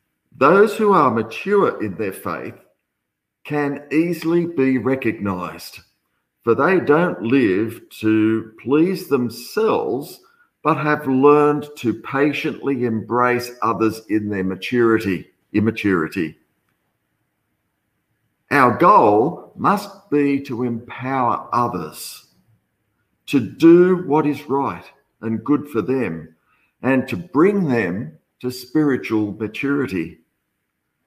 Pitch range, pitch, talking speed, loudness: 110-150 Hz, 130 Hz, 100 wpm, -19 LUFS